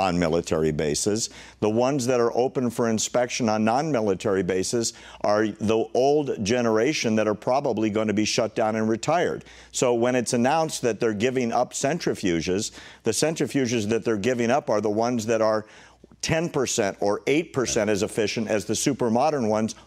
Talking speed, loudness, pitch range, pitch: 170 wpm, -24 LUFS, 105-125 Hz, 115 Hz